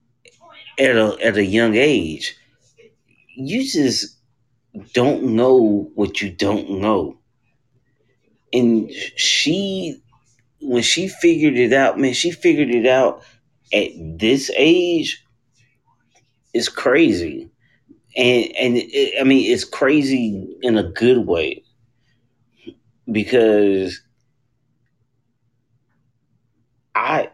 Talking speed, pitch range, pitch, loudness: 95 wpm, 120-150 Hz, 125 Hz, -17 LUFS